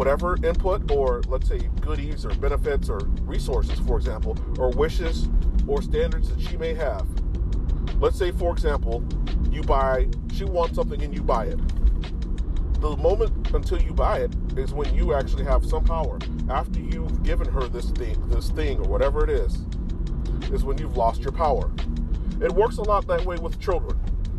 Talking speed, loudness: 175 wpm, -26 LUFS